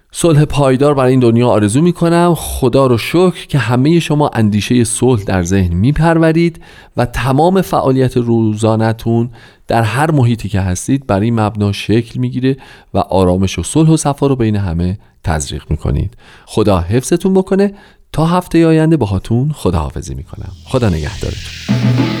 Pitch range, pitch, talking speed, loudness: 105-155 Hz, 125 Hz, 160 wpm, -13 LUFS